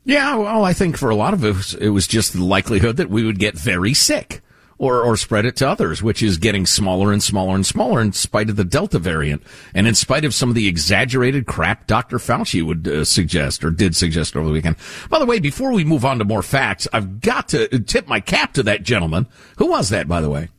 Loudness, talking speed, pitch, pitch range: -17 LUFS, 250 wpm, 110 Hz, 95-135 Hz